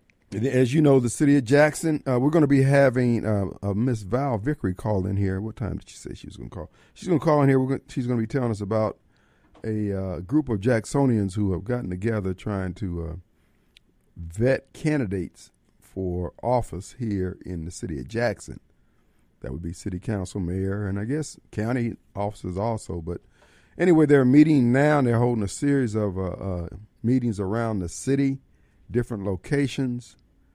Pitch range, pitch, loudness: 95-135 Hz, 110 Hz, -24 LUFS